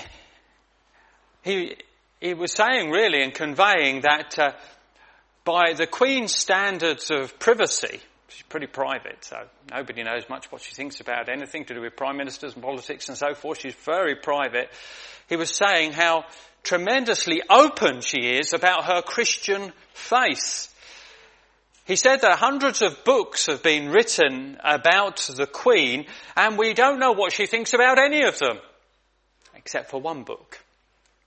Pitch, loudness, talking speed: 175 Hz, -21 LUFS, 150 wpm